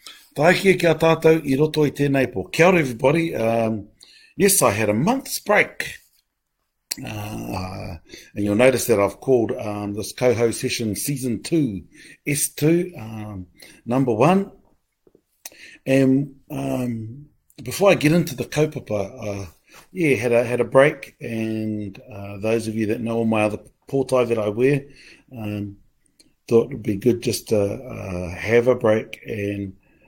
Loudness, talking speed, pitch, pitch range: -21 LUFS, 160 wpm, 120 Hz, 105-140 Hz